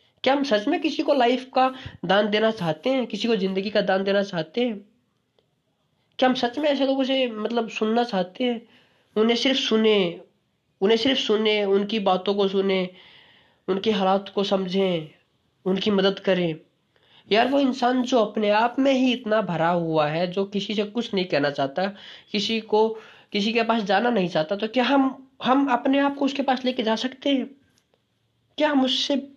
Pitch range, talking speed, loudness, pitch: 195-255 Hz, 185 wpm, -23 LUFS, 220 Hz